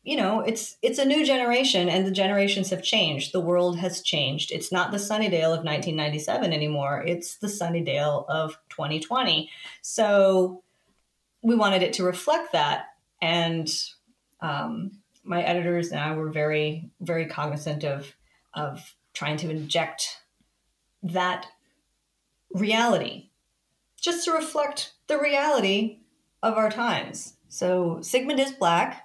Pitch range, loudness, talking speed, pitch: 155-220 Hz, -25 LUFS, 140 wpm, 180 Hz